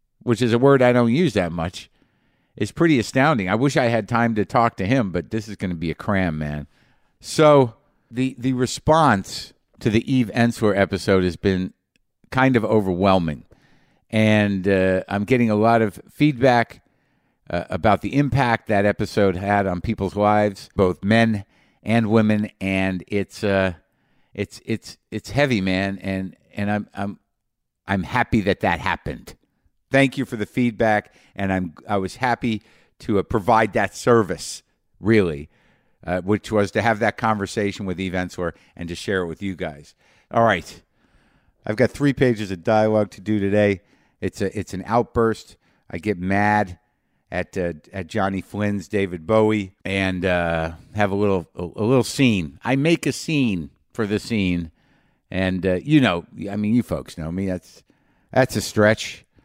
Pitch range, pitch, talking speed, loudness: 95-115 Hz, 105 Hz, 175 wpm, -21 LUFS